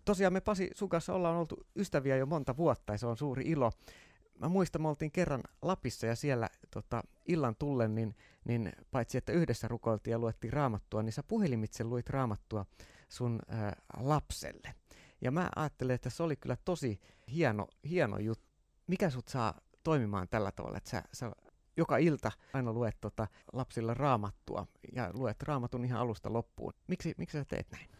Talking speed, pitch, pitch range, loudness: 175 wpm, 125 Hz, 110-155 Hz, -36 LUFS